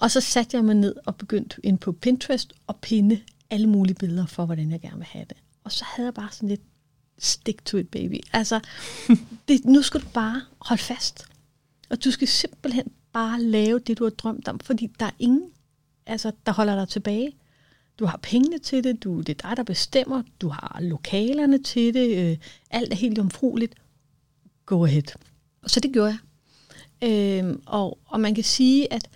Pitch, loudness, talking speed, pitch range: 220 Hz, -24 LUFS, 200 wpm, 185-245 Hz